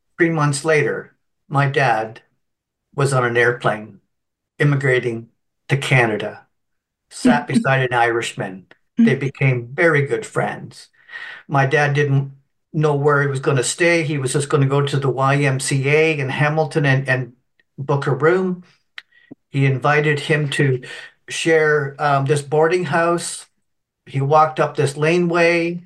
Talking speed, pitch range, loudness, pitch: 140 wpm, 135-160 Hz, -18 LUFS, 145 Hz